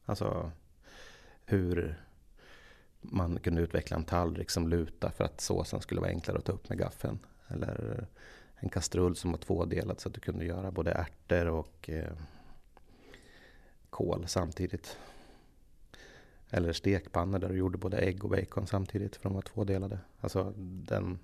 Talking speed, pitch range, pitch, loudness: 145 wpm, 85-95 Hz, 90 Hz, -35 LUFS